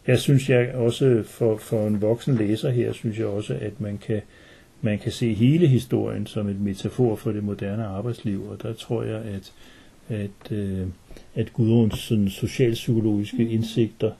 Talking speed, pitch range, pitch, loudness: 165 wpm, 105-120 Hz, 110 Hz, -24 LUFS